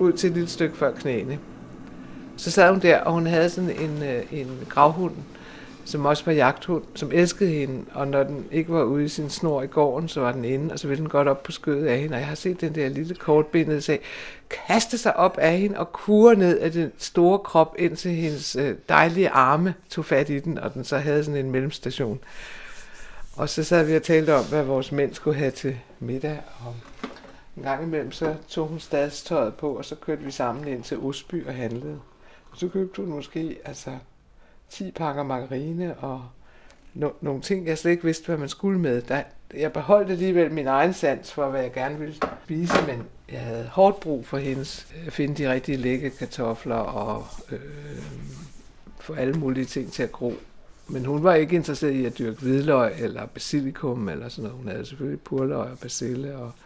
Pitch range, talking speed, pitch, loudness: 135-165 Hz, 210 wpm, 150 Hz, -24 LUFS